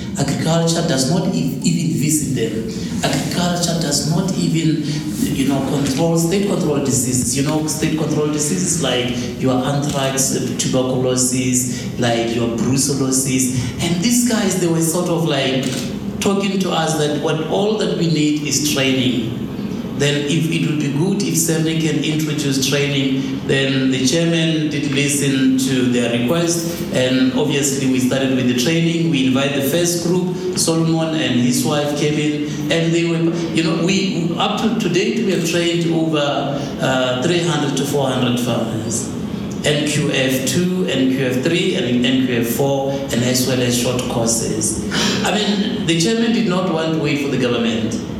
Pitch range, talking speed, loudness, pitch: 130-170 Hz, 155 wpm, -17 LUFS, 150 Hz